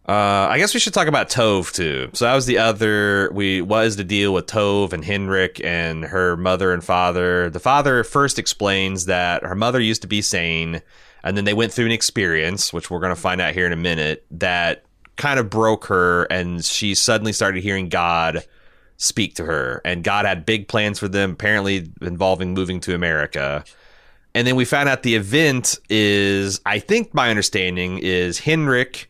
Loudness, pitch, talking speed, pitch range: -19 LUFS, 100 Hz, 195 wpm, 90-110 Hz